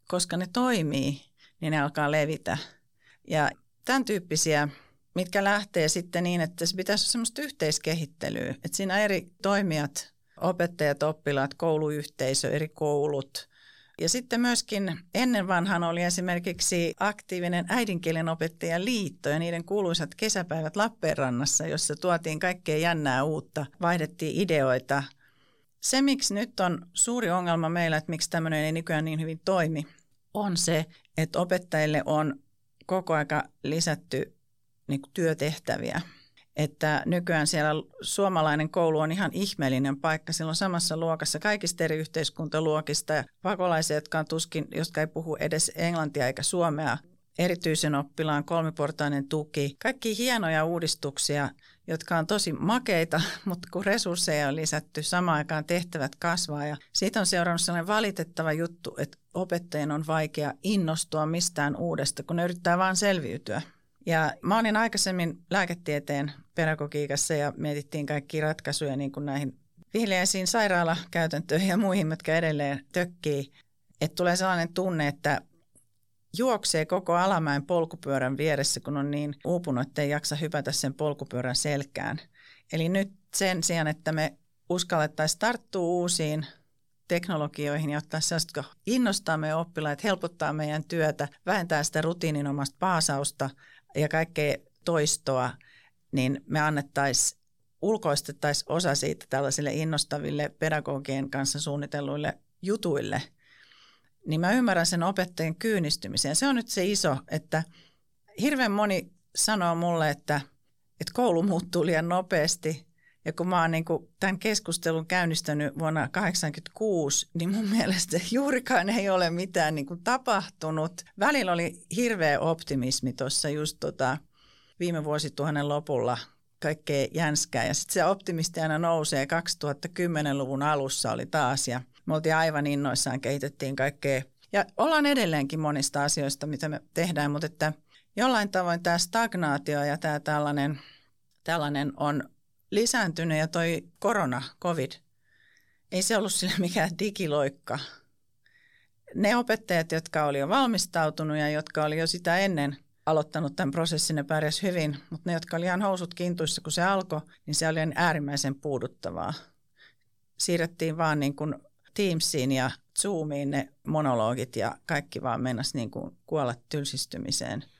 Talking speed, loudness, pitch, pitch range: 130 wpm, -28 LUFS, 160 Hz, 145-180 Hz